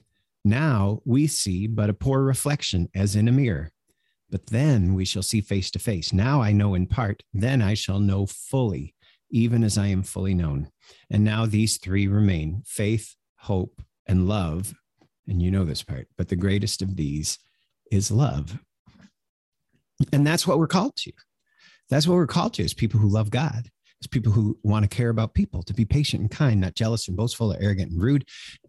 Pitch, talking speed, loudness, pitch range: 105 Hz, 195 wpm, -24 LUFS, 95-125 Hz